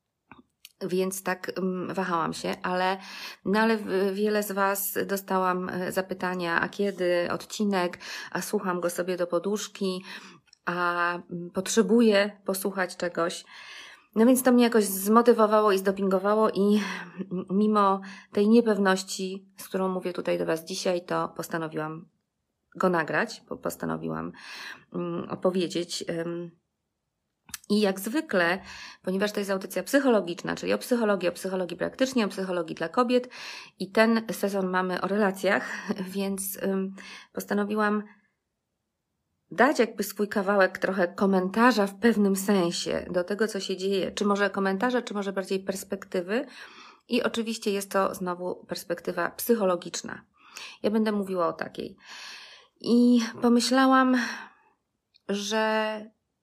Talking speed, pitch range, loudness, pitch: 120 wpm, 180-215 Hz, -26 LUFS, 195 Hz